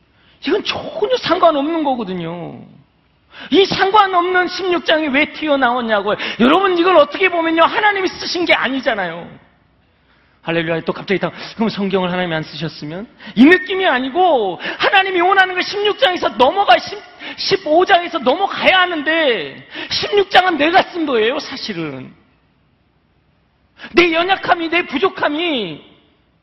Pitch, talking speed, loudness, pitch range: 330 Hz, 280 characters per minute, -15 LUFS, 250-370 Hz